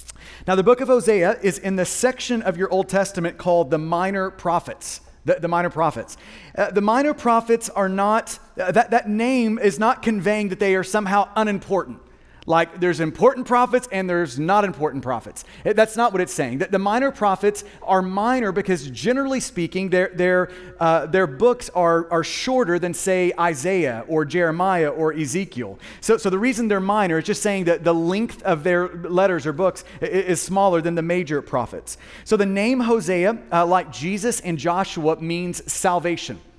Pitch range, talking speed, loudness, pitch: 170-210 Hz, 180 wpm, -21 LUFS, 190 Hz